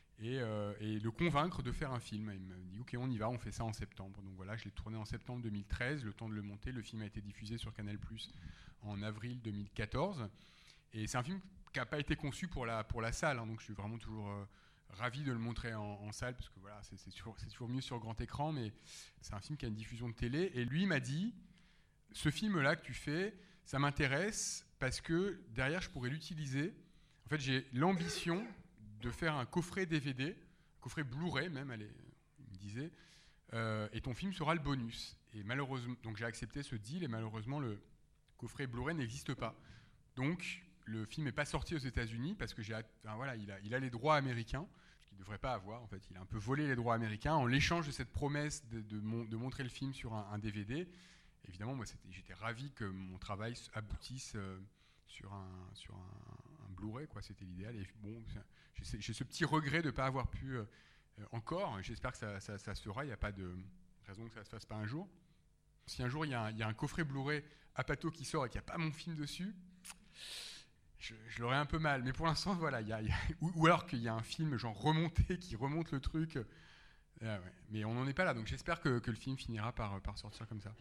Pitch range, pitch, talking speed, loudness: 110-150 Hz, 120 Hz, 240 wpm, -41 LUFS